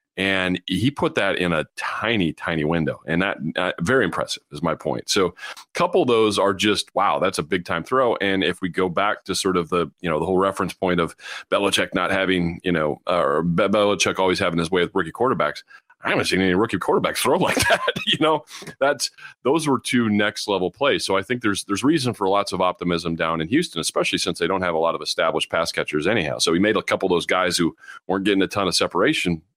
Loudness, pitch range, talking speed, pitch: -21 LUFS, 90-100 Hz, 240 wpm, 95 Hz